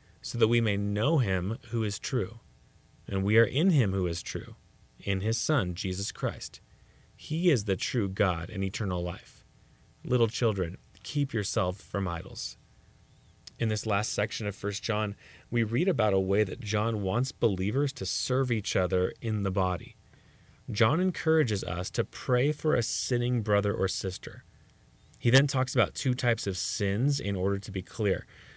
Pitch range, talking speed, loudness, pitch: 95-120 Hz, 175 wpm, -29 LUFS, 105 Hz